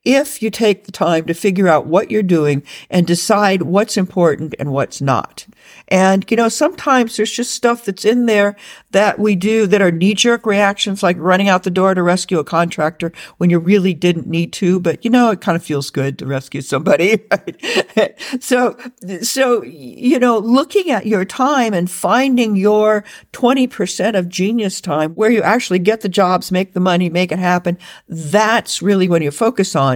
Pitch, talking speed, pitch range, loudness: 195 Hz, 190 wpm, 175-225 Hz, -15 LUFS